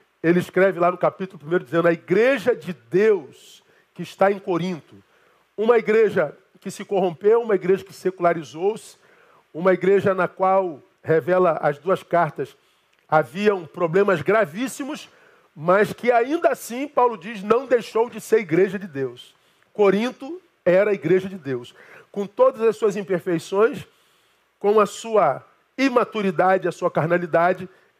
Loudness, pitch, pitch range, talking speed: -21 LUFS, 195 Hz, 175-220 Hz, 140 wpm